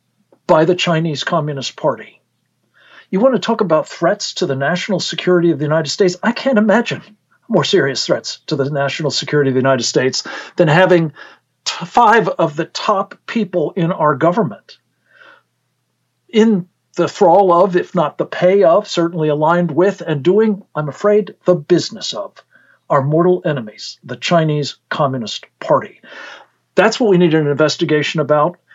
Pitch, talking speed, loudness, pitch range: 170 Hz, 160 wpm, -15 LUFS, 150-190 Hz